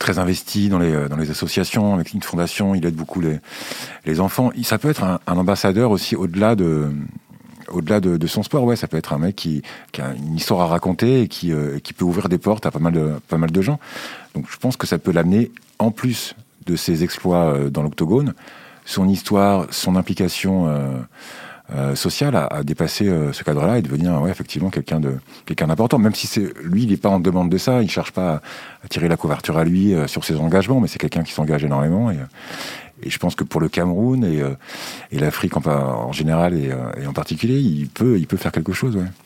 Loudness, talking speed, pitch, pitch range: -20 LUFS, 230 wpm, 90 Hz, 80-100 Hz